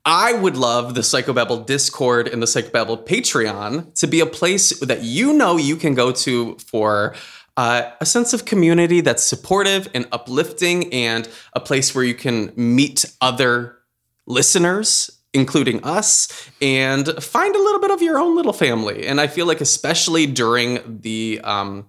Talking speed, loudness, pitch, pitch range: 165 wpm, -17 LUFS, 135 Hz, 120-170 Hz